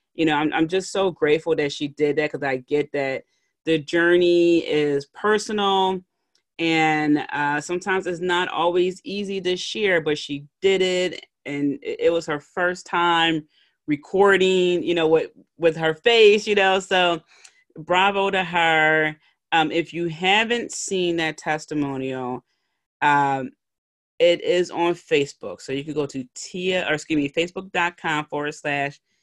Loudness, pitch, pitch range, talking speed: -21 LUFS, 165 Hz, 150-185 Hz, 155 wpm